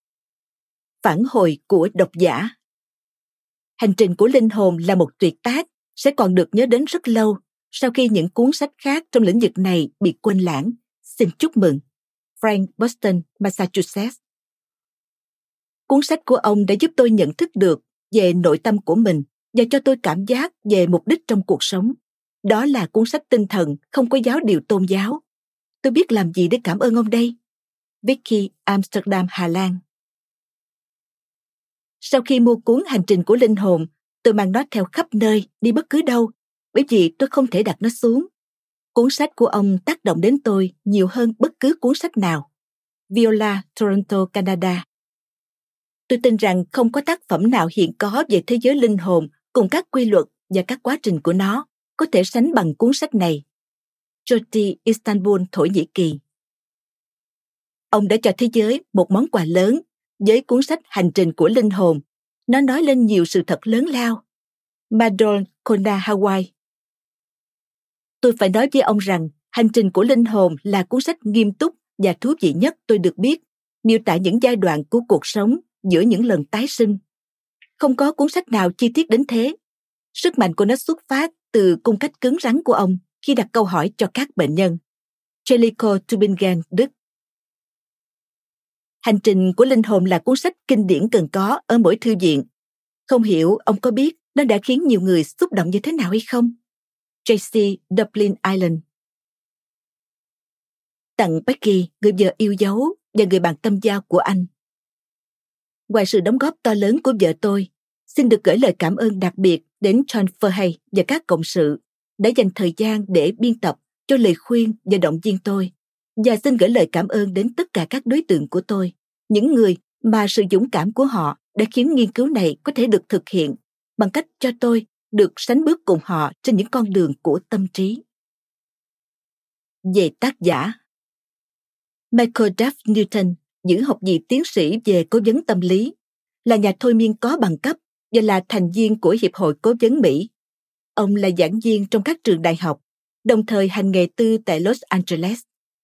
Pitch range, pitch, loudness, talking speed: 185-245 Hz, 215 Hz, -18 LUFS, 185 wpm